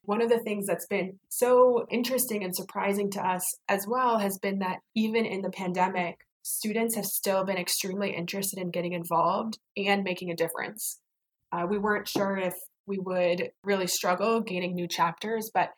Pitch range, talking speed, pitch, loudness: 180-215 Hz, 180 wpm, 195 Hz, -28 LUFS